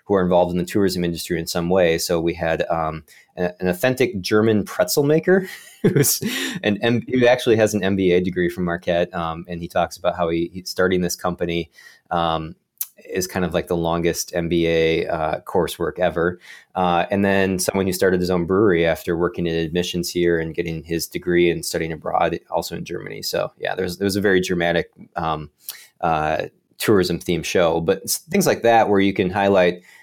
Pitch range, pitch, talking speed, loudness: 85-95 Hz, 90 Hz, 195 wpm, -20 LUFS